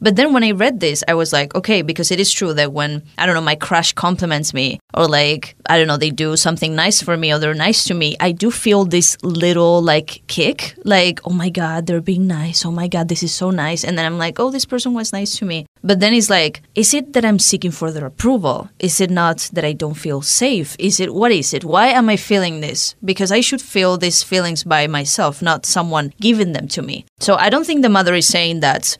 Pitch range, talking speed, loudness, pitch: 160-200 Hz, 255 wpm, -15 LUFS, 175 Hz